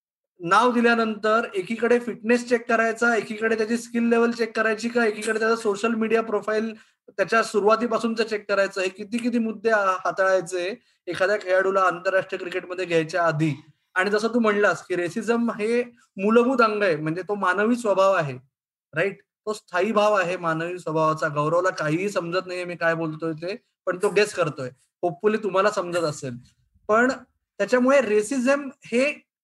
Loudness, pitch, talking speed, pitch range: -23 LUFS, 210 Hz, 155 wpm, 180-225 Hz